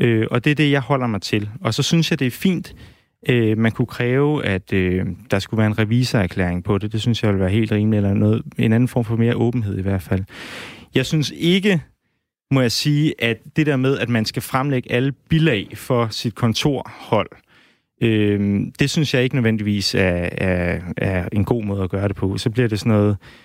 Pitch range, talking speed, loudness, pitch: 100-130 Hz, 225 wpm, -19 LUFS, 115 Hz